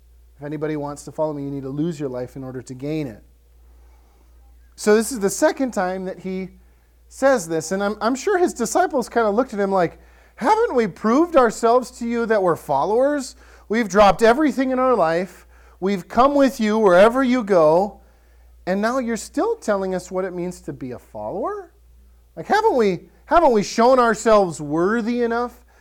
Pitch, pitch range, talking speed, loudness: 200 Hz, 150-240 Hz, 195 wpm, -19 LUFS